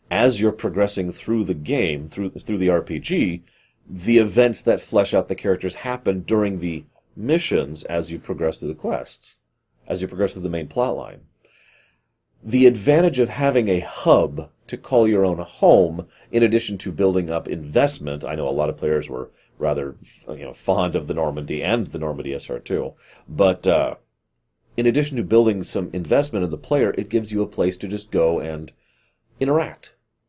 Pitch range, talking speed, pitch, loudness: 85-115 Hz, 180 wpm, 95 Hz, -21 LUFS